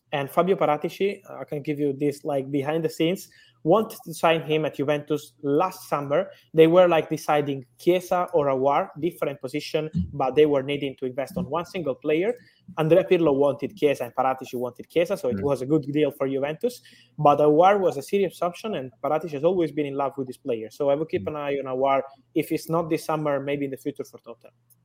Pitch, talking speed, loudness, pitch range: 150 Hz, 215 wpm, -24 LUFS, 140-165 Hz